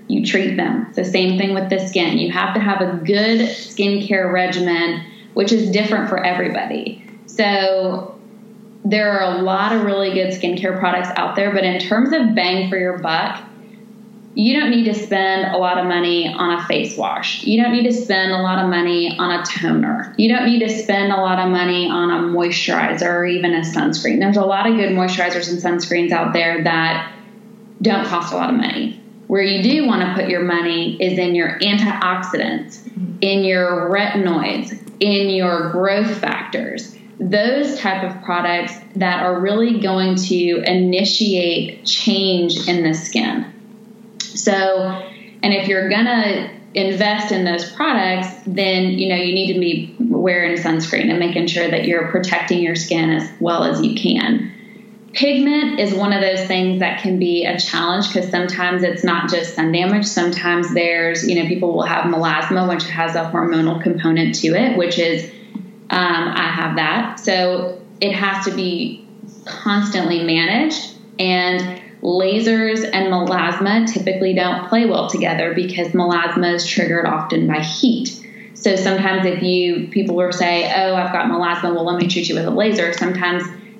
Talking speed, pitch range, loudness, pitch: 180 wpm, 175-215 Hz, -17 LUFS, 190 Hz